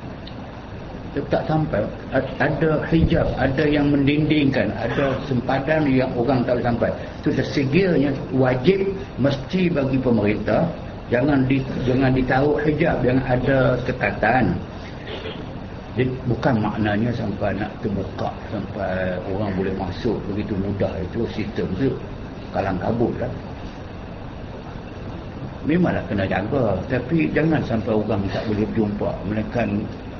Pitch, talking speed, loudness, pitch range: 120 Hz, 120 wpm, -21 LUFS, 105-135 Hz